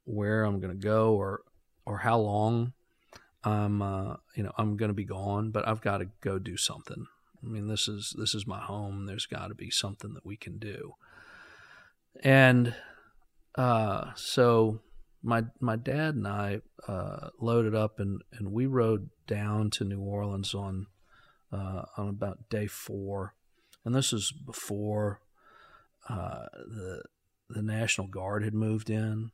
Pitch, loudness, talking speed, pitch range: 105 Hz, -31 LUFS, 155 wpm, 100-115 Hz